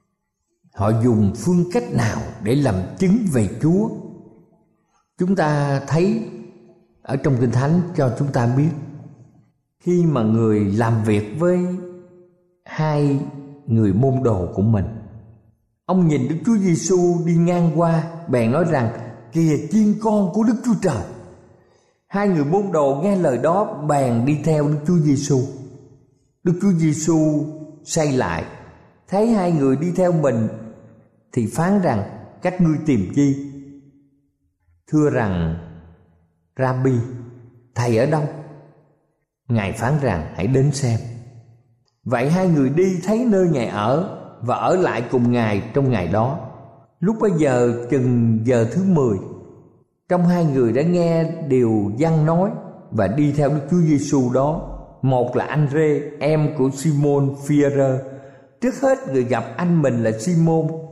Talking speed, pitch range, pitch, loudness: 145 wpm, 120-170 Hz, 140 Hz, -19 LUFS